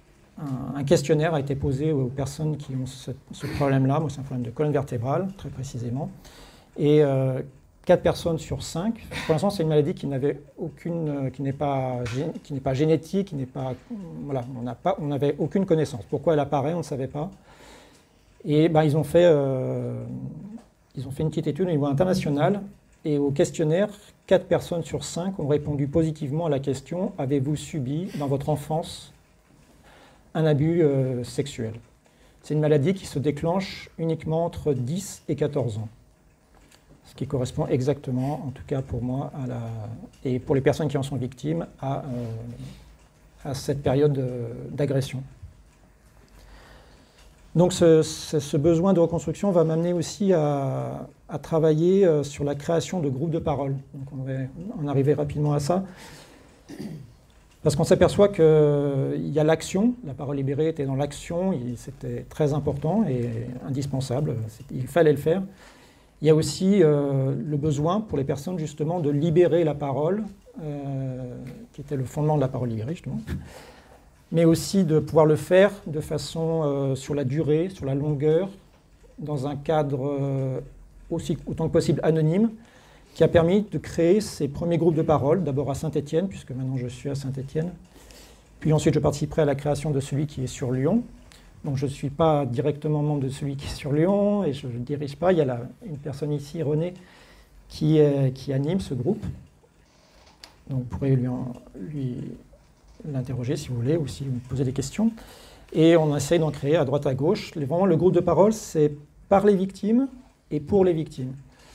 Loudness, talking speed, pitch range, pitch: -25 LUFS, 180 wpm, 135-165 Hz, 150 Hz